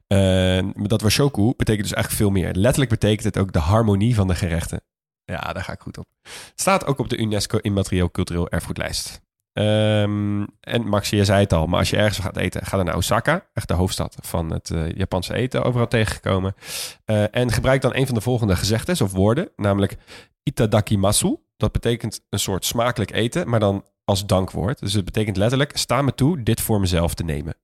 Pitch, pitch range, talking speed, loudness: 105 Hz, 95-115 Hz, 205 wpm, -21 LUFS